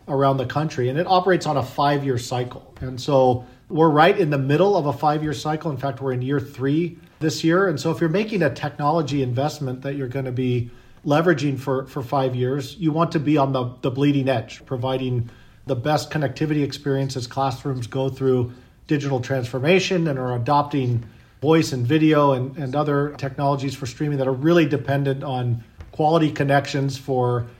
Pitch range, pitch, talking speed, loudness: 130-150 Hz, 140 Hz, 190 wpm, -22 LUFS